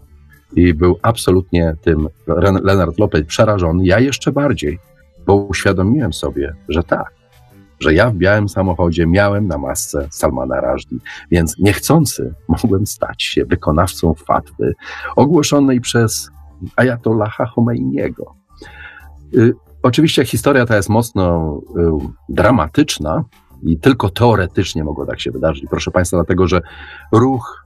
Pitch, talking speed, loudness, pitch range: 90 Hz, 125 wpm, -15 LUFS, 80-110 Hz